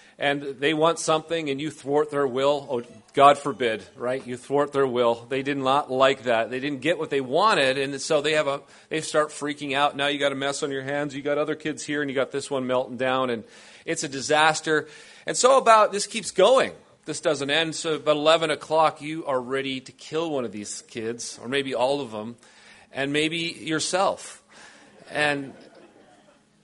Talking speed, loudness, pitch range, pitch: 205 wpm, -24 LUFS, 135-155 Hz, 145 Hz